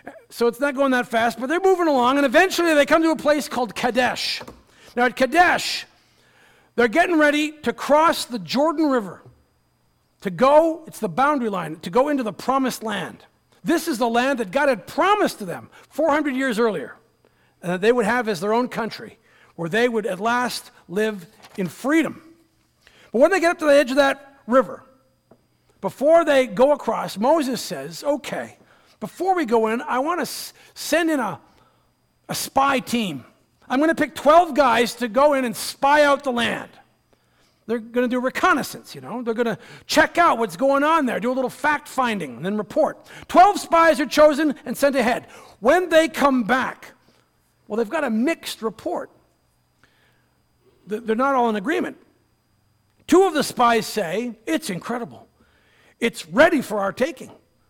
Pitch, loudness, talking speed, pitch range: 255 Hz, -20 LUFS, 180 wpm, 225-300 Hz